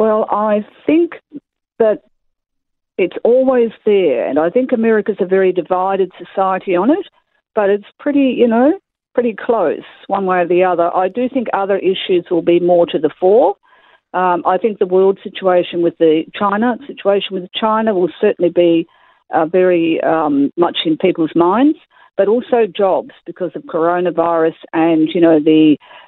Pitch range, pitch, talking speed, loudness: 175-245 Hz, 195 Hz, 170 wpm, -15 LUFS